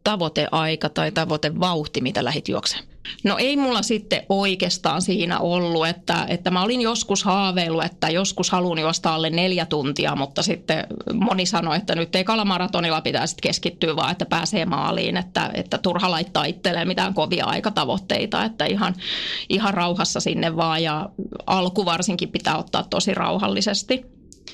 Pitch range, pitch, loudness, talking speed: 165-200 Hz, 180 Hz, -22 LUFS, 150 wpm